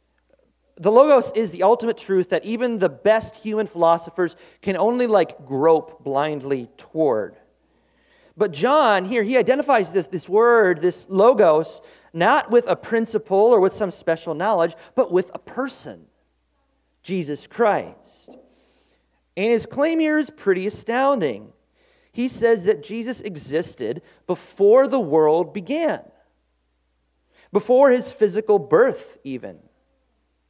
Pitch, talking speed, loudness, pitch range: 205 Hz, 125 wpm, -20 LUFS, 165-240 Hz